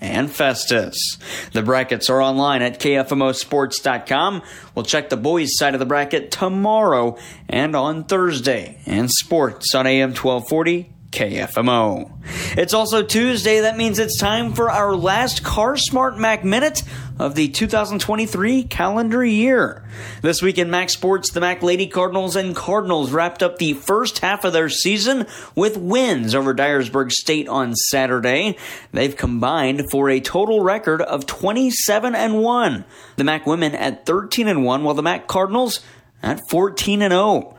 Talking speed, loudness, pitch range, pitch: 155 wpm, -18 LUFS, 135-210 Hz, 175 Hz